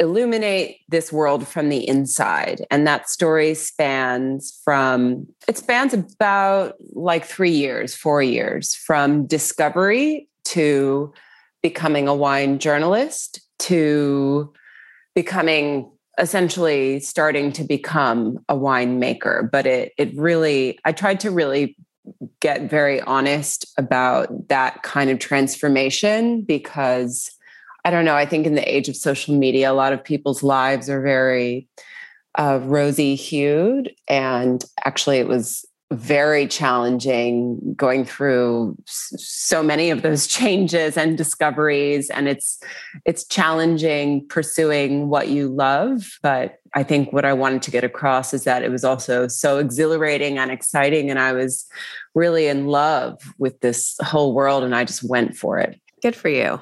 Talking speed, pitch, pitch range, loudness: 140 wpm, 145 Hz, 135-160 Hz, -19 LUFS